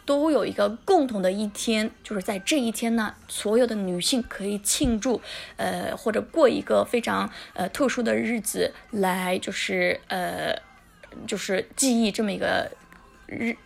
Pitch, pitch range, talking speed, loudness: 225 Hz, 205-245 Hz, 230 characters per minute, -25 LUFS